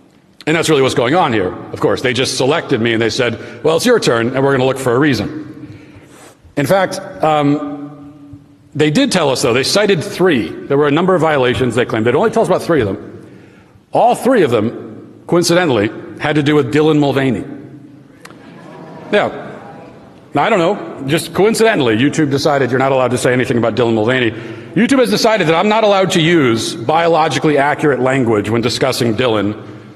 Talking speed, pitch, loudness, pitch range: 195 wpm, 145 Hz, -14 LUFS, 130-165 Hz